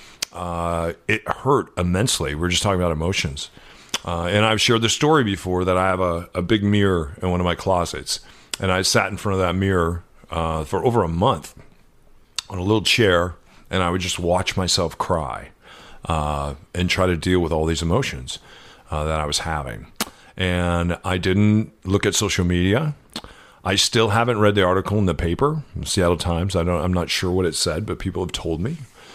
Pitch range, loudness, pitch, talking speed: 85-100 Hz, -21 LUFS, 90 Hz, 200 wpm